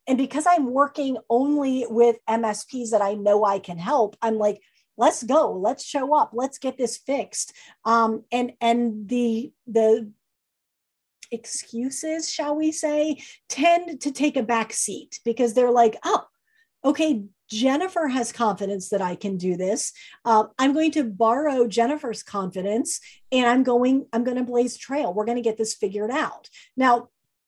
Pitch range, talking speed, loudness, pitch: 220-280 Hz, 165 wpm, -23 LUFS, 240 Hz